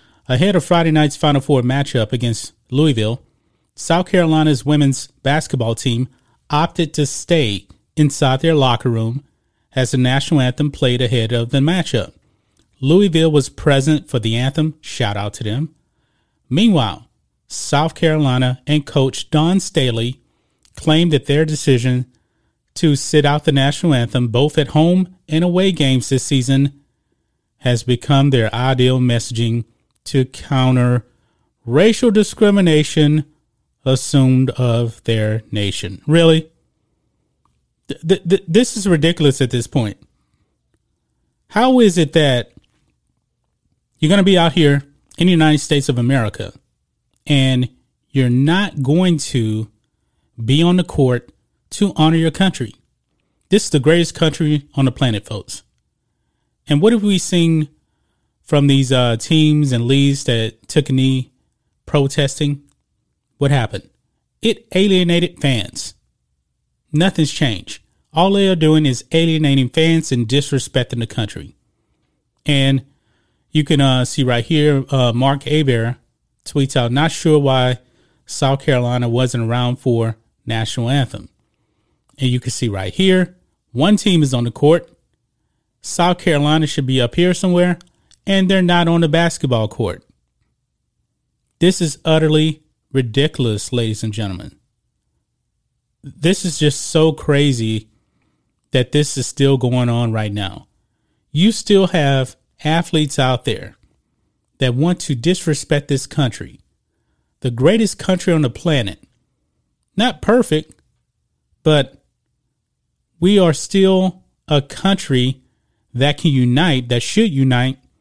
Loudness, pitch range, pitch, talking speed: -16 LUFS, 120-160 Hz, 140 Hz, 130 wpm